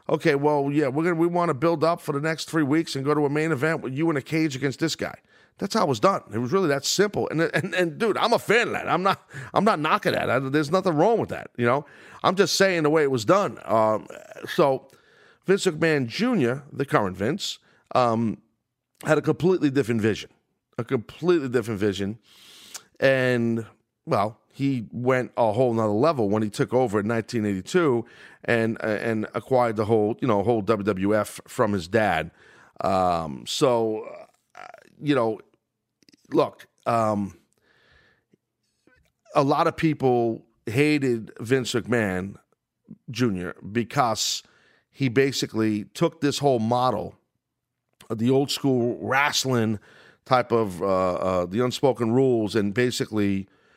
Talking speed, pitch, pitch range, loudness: 165 wpm, 125 Hz, 110-150 Hz, -24 LUFS